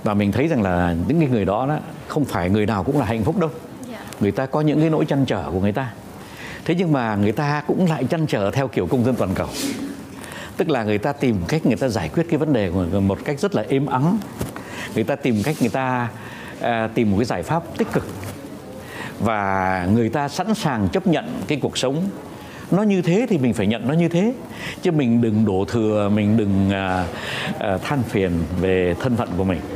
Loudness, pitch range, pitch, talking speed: -21 LUFS, 100-150 Hz, 120 Hz, 230 wpm